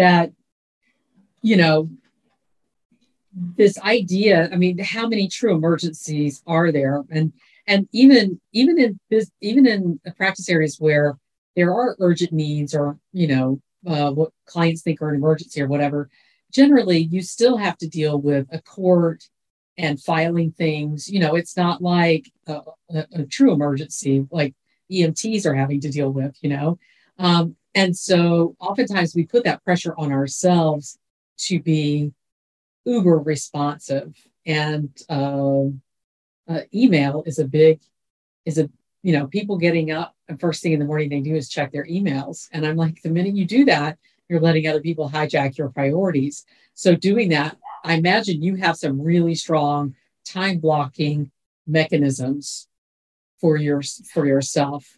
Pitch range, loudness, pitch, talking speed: 145-180 Hz, -20 LUFS, 160 Hz, 155 wpm